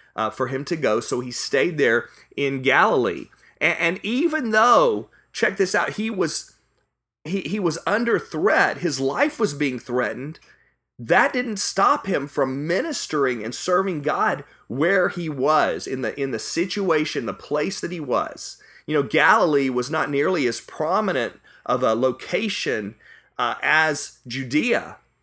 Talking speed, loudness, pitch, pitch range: 155 wpm, -22 LUFS, 155 Hz, 135-190 Hz